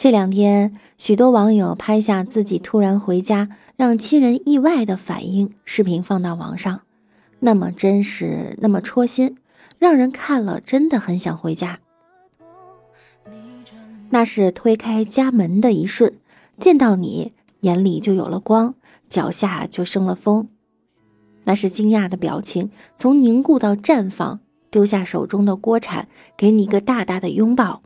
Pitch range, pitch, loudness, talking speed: 190-240 Hz, 210 Hz, -18 LUFS, 215 characters per minute